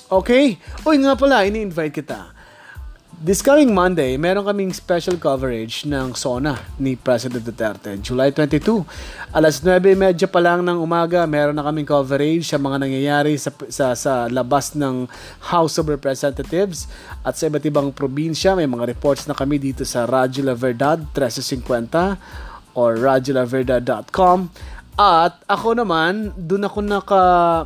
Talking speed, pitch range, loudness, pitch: 140 wpm, 135-180 Hz, -18 LUFS, 150 Hz